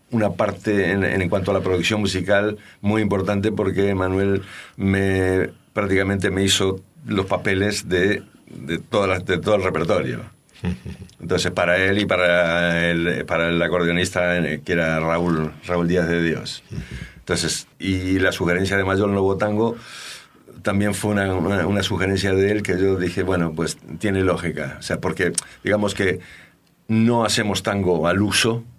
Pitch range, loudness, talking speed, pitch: 90-100 Hz, -21 LUFS, 160 wpm, 95 Hz